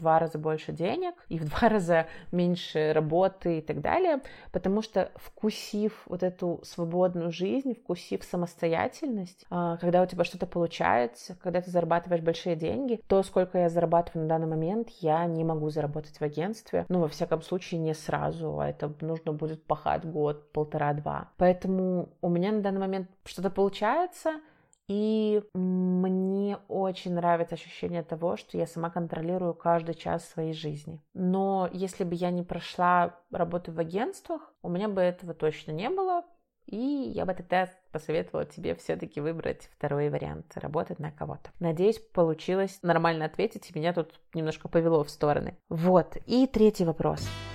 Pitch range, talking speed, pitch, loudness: 160-190 Hz, 160 wpm, 175 Hz, -29 LUFS